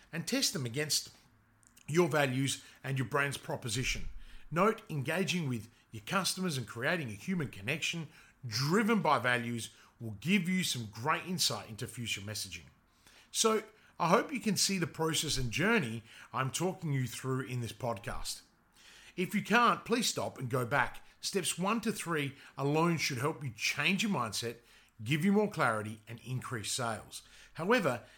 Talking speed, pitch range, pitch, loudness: 160 wpm, 115-175 Hz, 140 Hz, -33 LUFS